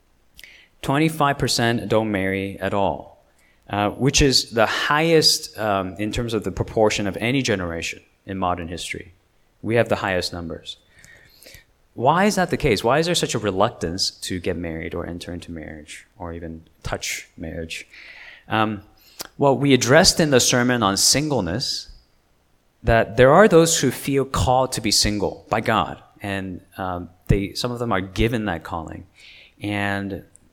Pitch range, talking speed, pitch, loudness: 90-125 Hz, 165 wpm, 105 Hz, -20 LUFS